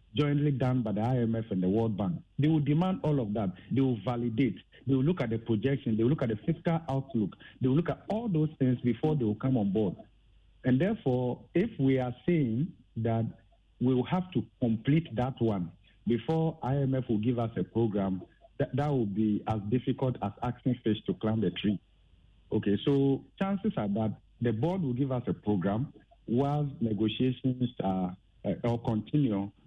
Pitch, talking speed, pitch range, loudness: 125 Hz, 195 wpm, 110-140 Hz, -30 LUFS